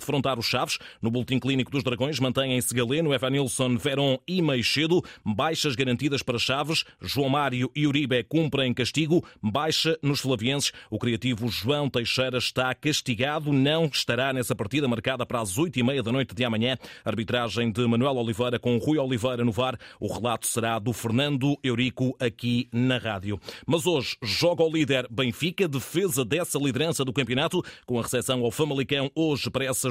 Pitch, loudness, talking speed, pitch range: 130 Hz, -26 LUFS, 170 wpm, 120-145 Hz